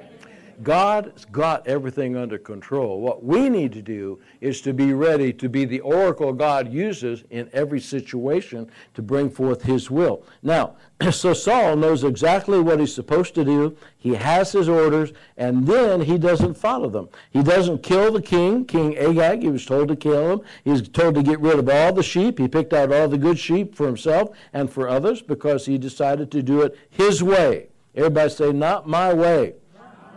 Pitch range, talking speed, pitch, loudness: 135-175 Hz, 190 wpm, 150 Hz, -20 LUFS